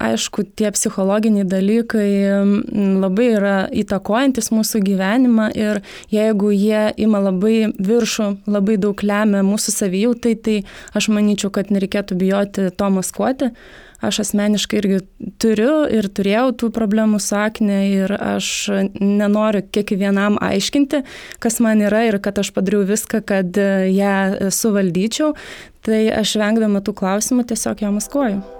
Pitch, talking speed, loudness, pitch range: 210 Hz, 130 wpm, -17 LUFS, 200-220 Hz